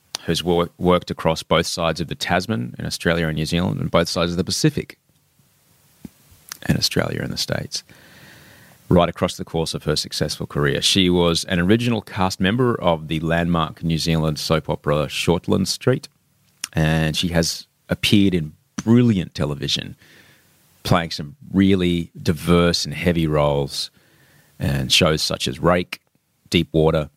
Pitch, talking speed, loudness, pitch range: 85 Hz, 150 wpm, -20 LUFS, 80-90 Hz